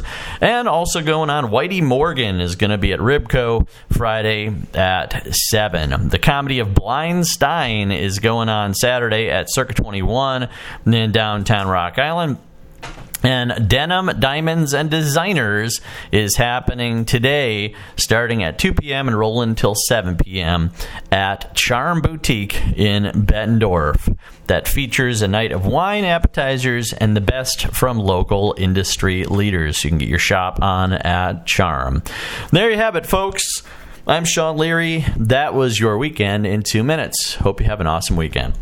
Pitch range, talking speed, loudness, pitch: 95-135 Hz, 150 wpm, -17 LUFS, 110 Hz